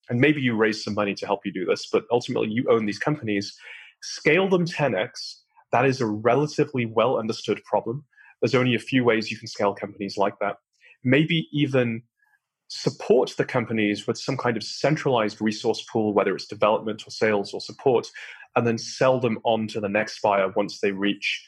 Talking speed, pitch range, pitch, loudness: 195 wpm, 105-130 Hz, 115 Hz, -24 LUFS